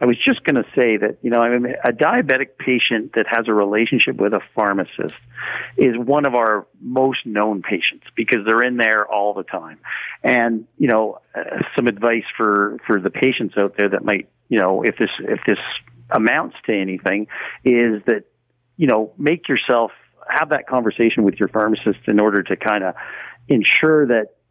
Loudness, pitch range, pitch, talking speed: -18 LUFS, 105-120 Hz, 110 Hz, 190 wpm